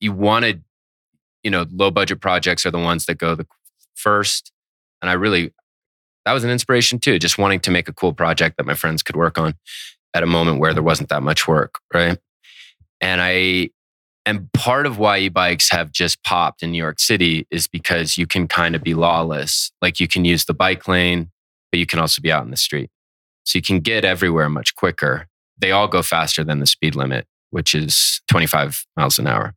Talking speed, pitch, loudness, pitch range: 215 wpm, 85 Hz, -17 LUFS, 80-95 Hz